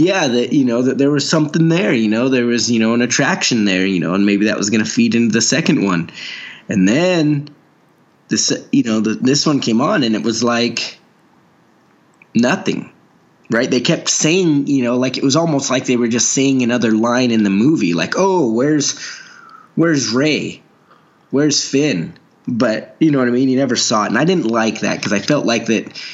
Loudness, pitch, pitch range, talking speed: -15 LUFS, 130 Hz, 115-150 Hz, 215 wpm